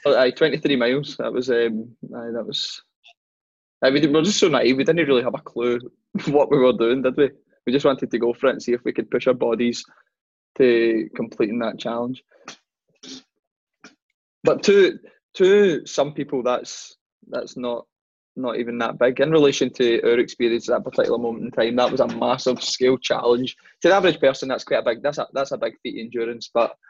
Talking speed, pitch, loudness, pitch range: 205 wpm, 125 Hz, -21 LUFS, 120-140 Hz